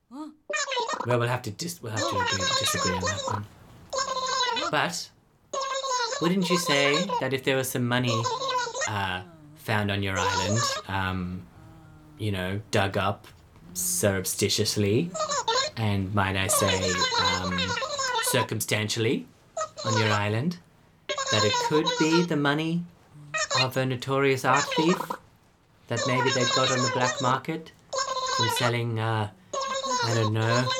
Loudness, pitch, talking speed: -26 LUFS, 130 Hz, 130 wpm